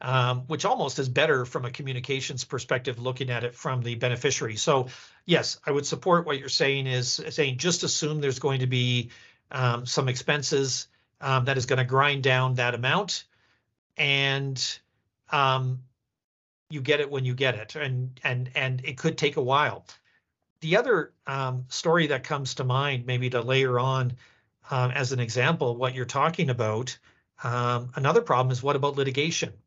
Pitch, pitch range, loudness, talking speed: 130 Hz, 125-145 Hz, -26 LUFS, 175 wpm